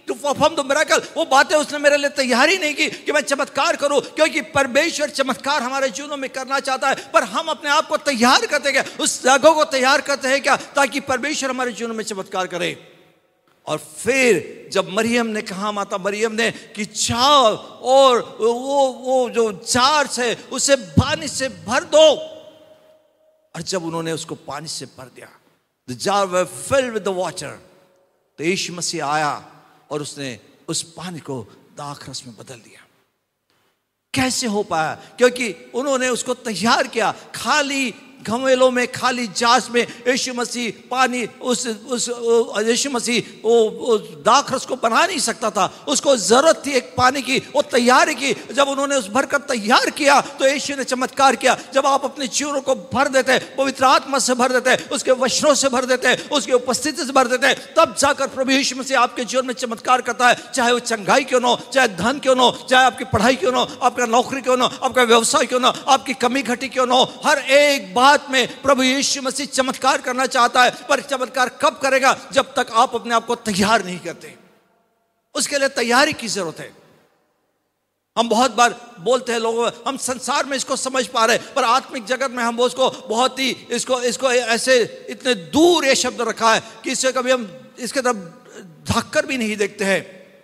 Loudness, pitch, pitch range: -18 LUFS, 255 Hz, 230-275 Hz